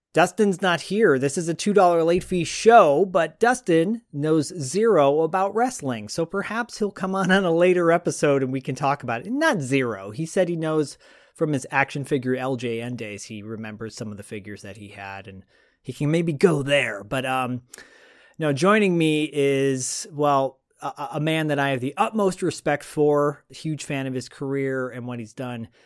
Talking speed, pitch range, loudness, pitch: 200 wpm, 130-175 Hz, -22 LUFS, 145 Hz